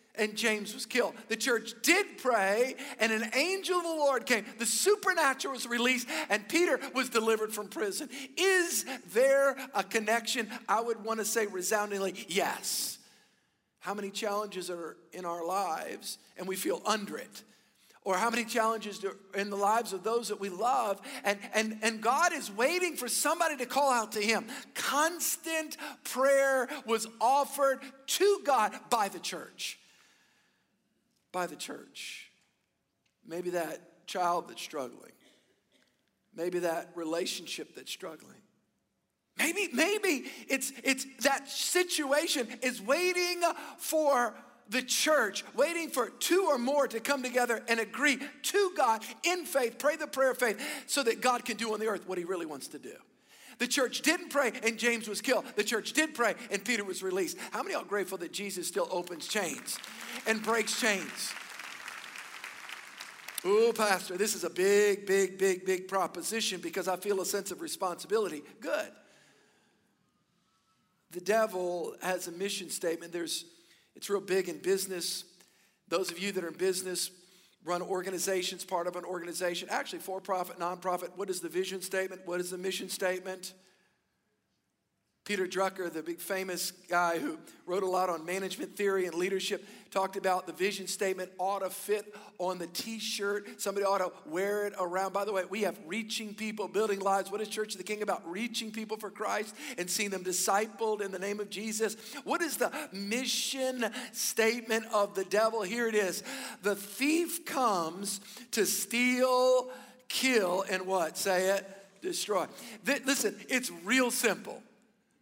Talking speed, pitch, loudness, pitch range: 165 wpm, 215 Hz, -31 LUFS, 190-255 Hz